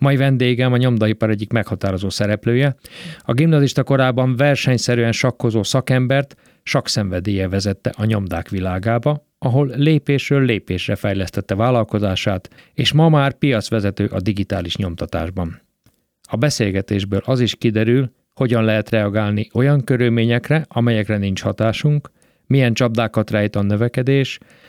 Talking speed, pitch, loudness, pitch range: 115 wpm, 115 Hz, -18 LUFS, 105-135 Hz